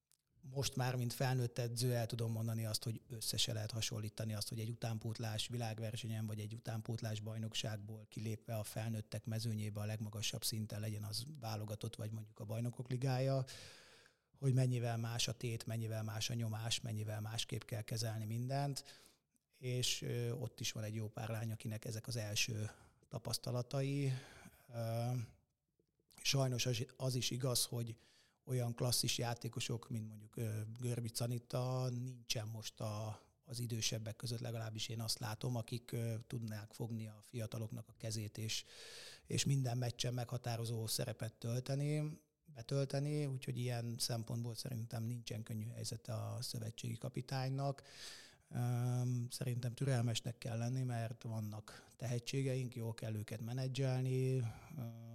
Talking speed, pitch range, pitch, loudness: 130 wpm, 110-125 Hz, 120 Hz, -42 LUFS